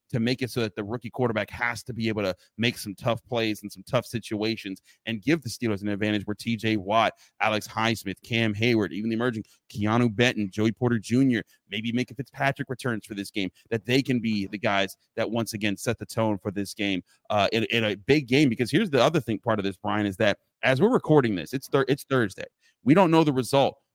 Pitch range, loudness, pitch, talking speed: 105-125 Hz, -26 LUFS, 115 Hz, 240 wpm